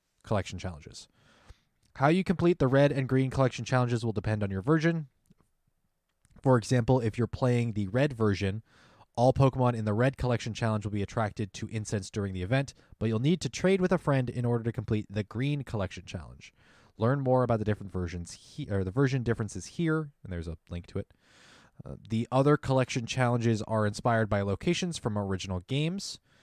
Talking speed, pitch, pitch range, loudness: 195 wpm, 115 Hz, 105-135 Hz, -29 LUFS